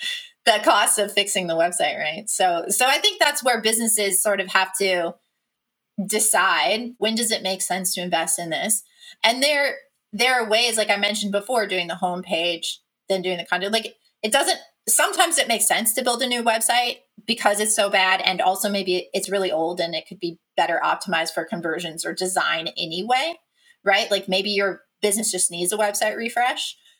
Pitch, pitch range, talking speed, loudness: 205 Hz, 185-235 Hz, 195 wpm, -21 LUFS